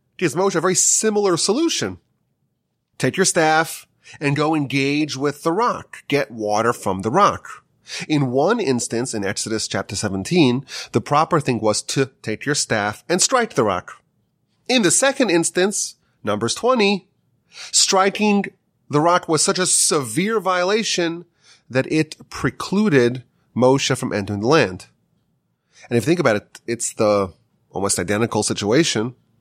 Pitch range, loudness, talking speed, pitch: 115-180 Hz, -19 LUFS, 145 wpm, 145 Hz